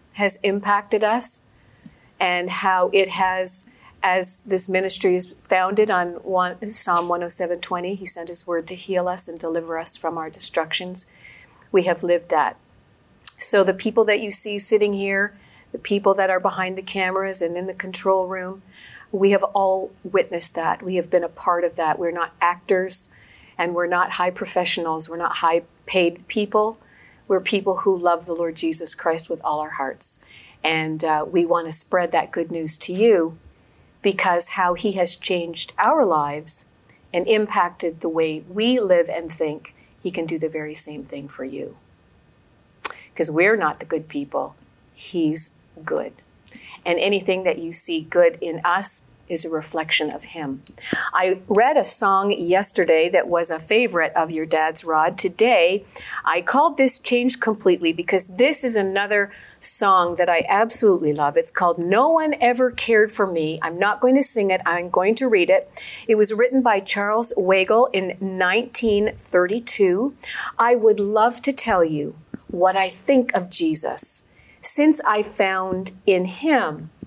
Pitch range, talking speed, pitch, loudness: 170-210 Hz, 170 wpm, 185 Hz, -20 LUFS